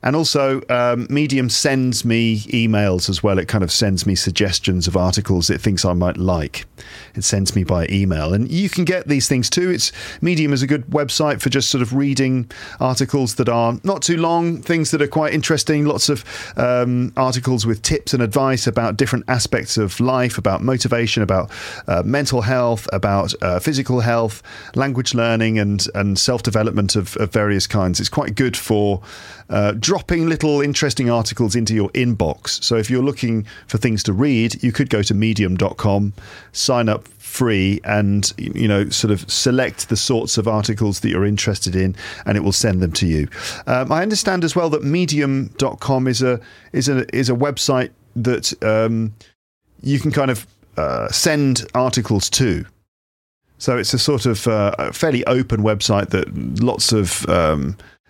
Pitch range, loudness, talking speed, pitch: 105-135 Hz, -18 LUFS, 180 wpm, 115 Hz